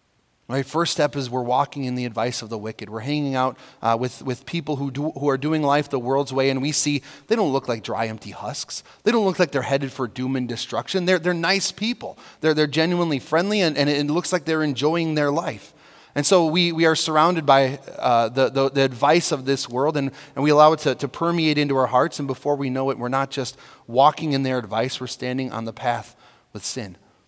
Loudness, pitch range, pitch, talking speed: -22 LUFS, 125-155 Hz, 135 Hz, 240 wpm